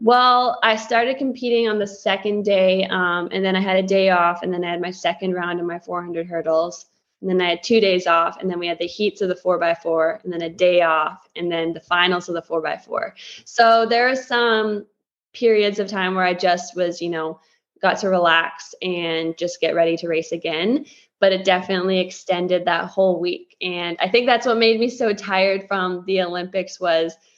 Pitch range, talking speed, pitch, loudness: 170-205 Hz, 225 wpm, 180 Hz, -20 LUFS